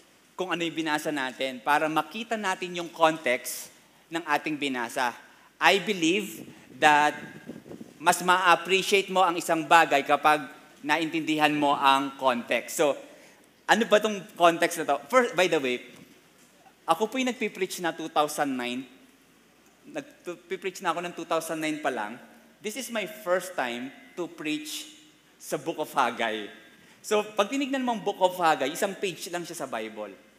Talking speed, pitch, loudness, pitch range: 150 wpm, 165 Hz, -26 LUFS, 150-190 Hz